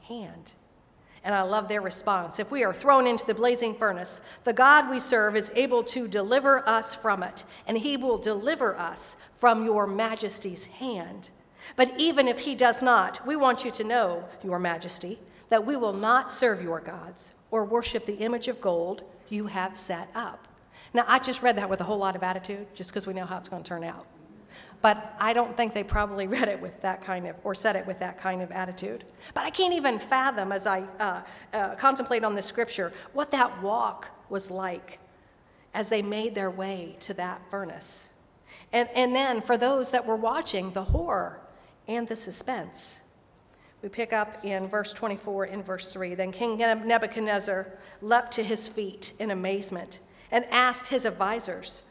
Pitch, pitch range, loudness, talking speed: 215 Hz, 190-240 Hz, -27 LUFS, 190 wpm